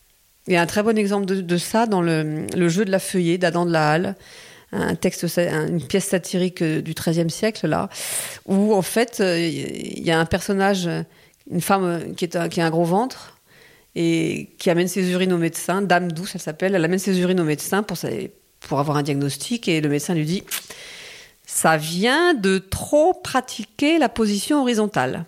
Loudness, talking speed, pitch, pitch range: -21 LUFS, 195 wpm, 180 Hz, 170-205 Hz